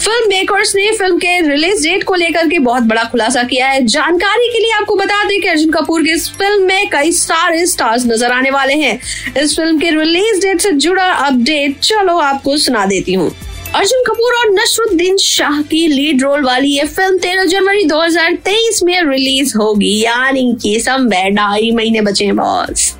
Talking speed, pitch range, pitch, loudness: 180 wpm, 260-385 Hz, 320 Hz, -11 LUFS